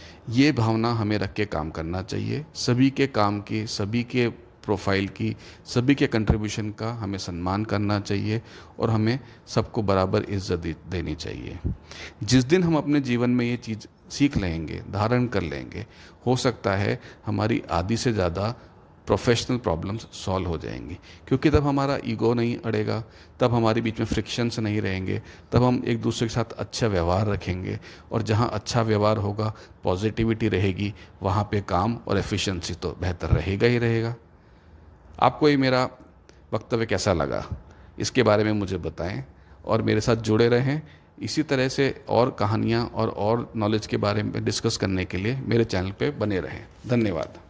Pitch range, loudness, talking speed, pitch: 95-120 Hz, -25 LUFS, 165 wpm, 110 Hz